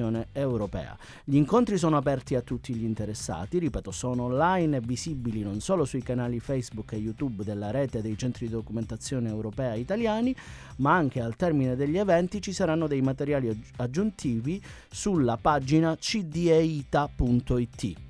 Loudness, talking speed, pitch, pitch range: -28 LUFS, 145 wpm, 130 Hz, 115-160 Hz